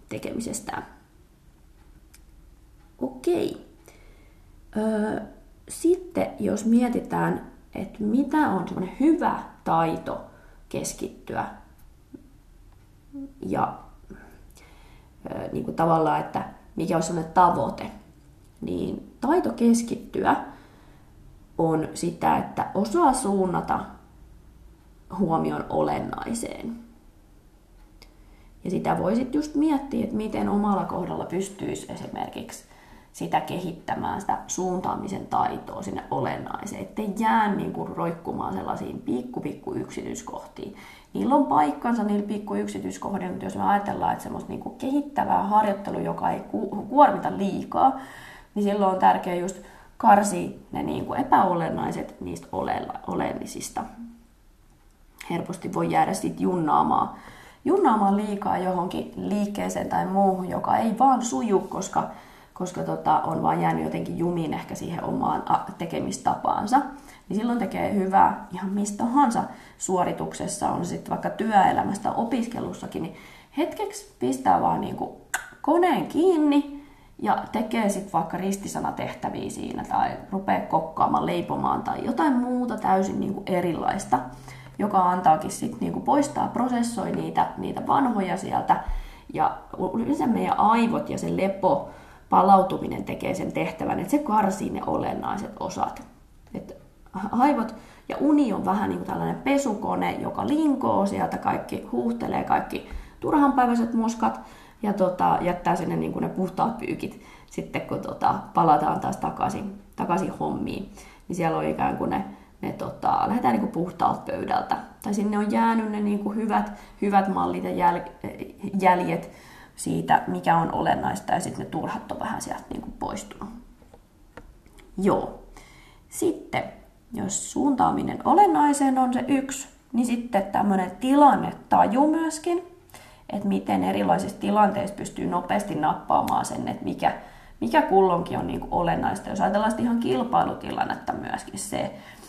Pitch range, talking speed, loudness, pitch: 180-265 Hz, 120 wpm, -25 LUFS, 205 Hz